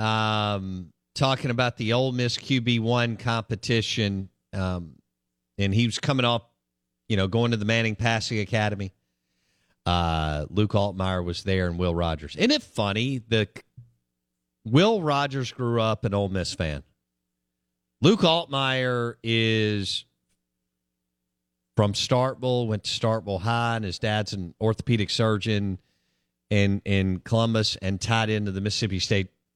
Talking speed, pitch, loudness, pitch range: 135 wpm, 105 Hz, -25 LUFS, 85-115 Hz